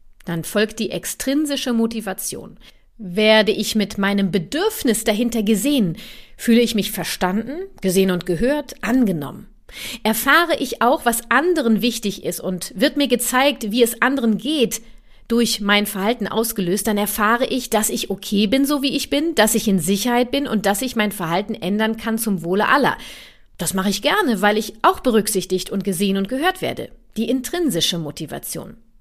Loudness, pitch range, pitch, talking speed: -19 LUFS, 200-255 Hz, 220 Hz, 170 wpm